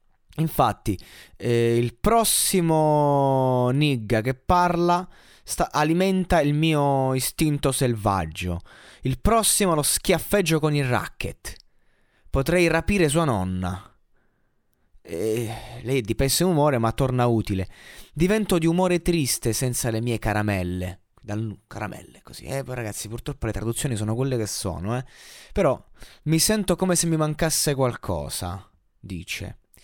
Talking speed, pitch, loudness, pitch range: 125 wpm, 130 Hz, -23 LUFS, 110-160 Hz